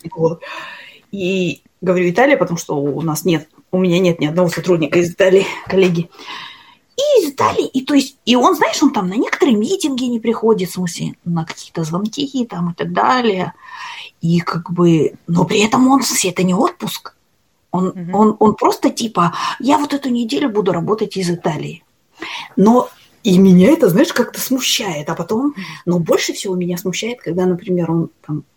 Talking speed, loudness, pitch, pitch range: 185 wpm, -16 LUFS, 190 Hz, 175-255 Hz